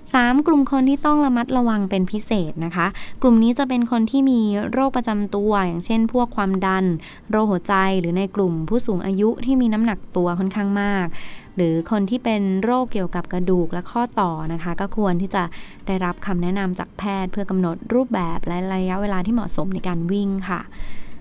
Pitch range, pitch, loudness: 180-230 Hz, 200 Hz, -21 LUFS